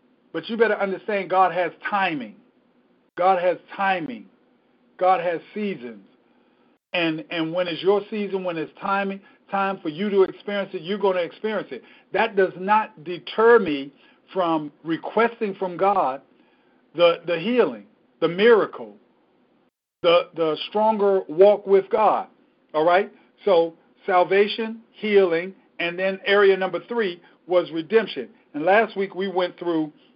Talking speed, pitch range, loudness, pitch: 140 wpm, 175-205 Hz, -22 LUFS, 190 Hz